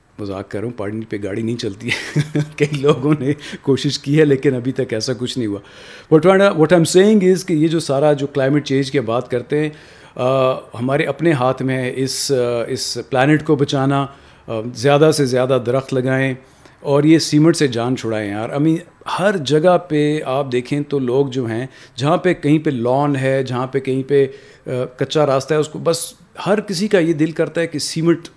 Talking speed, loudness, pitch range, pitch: 205 wpm, -17 LUFS, 130-155 Hz, 140 Hz